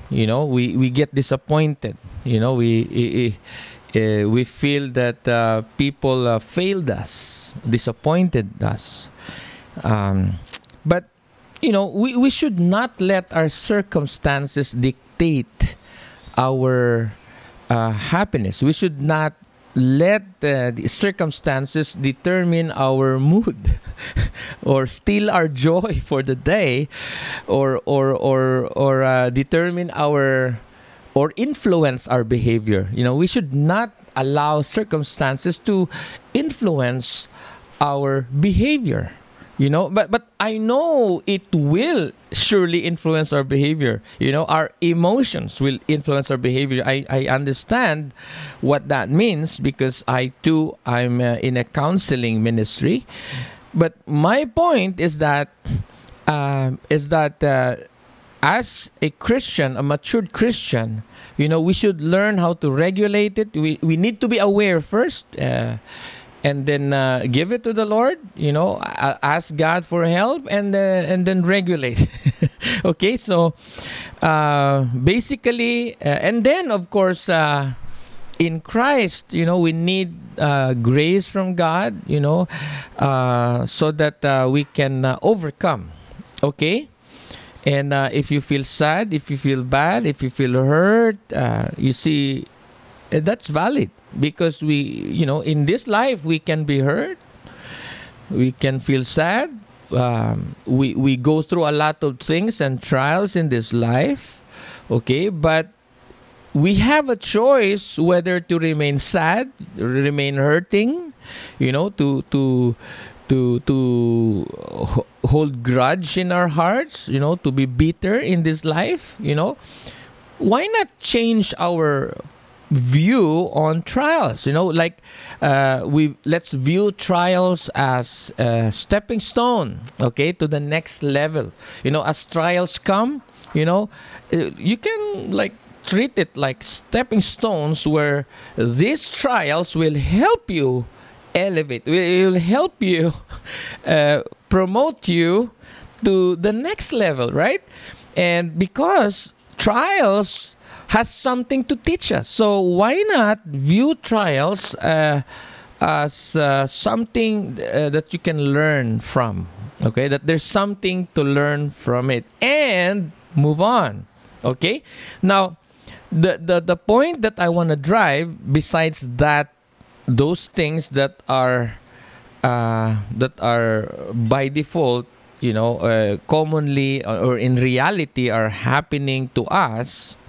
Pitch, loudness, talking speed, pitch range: 150 Hz, -19 LUFS, 130 wpm, 130-185 Hz